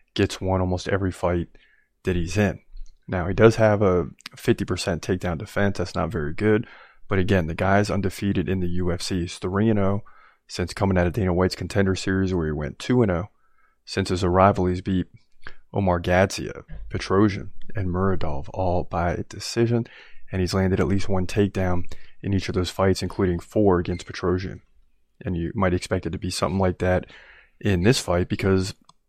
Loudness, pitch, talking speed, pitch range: -24 LUFS, 95 Hz, 175 wpm, 90-100 Hz